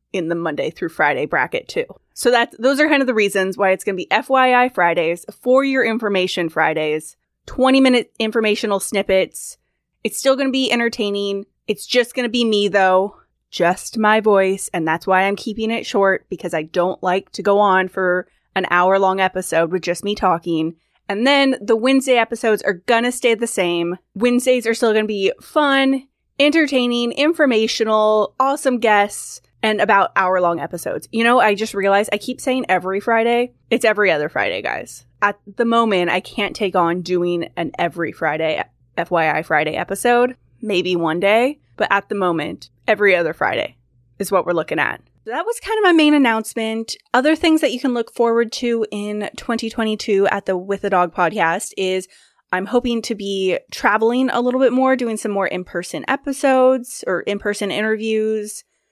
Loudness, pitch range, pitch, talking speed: -18 LUFS, 185-245 Hz, 210 Hz, 185 wpm